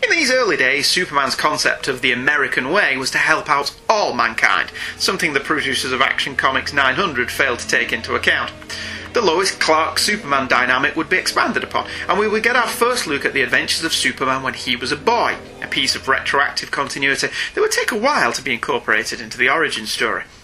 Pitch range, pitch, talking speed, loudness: 160-260 Hz, 220 Hz, 210 wpm, -17 LUFS